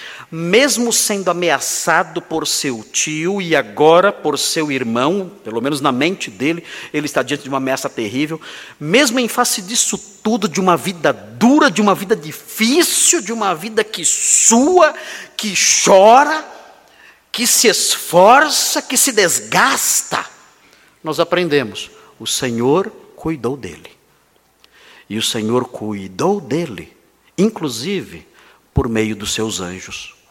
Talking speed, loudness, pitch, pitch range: 130 wpm, -15 LUFS, 175 Hz, 140-225 Hz